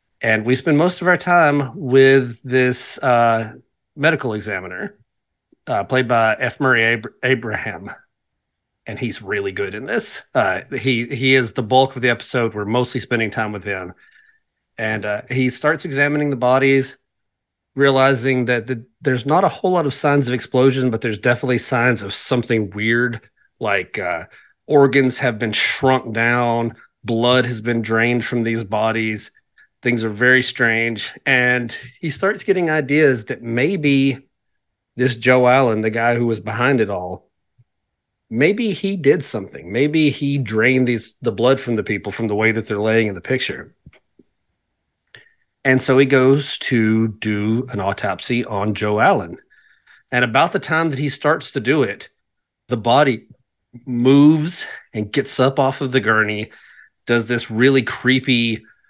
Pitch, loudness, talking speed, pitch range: 125 Hz, -18 LUFS, 160 wpm, 115-135 Hz